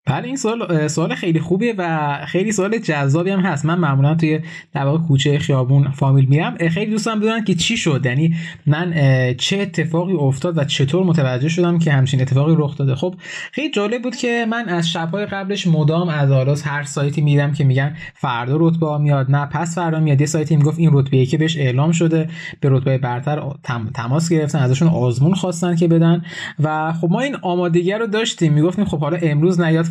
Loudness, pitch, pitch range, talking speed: -17 LUFS, 160 Hz, 145-175 Hz, 195 wpm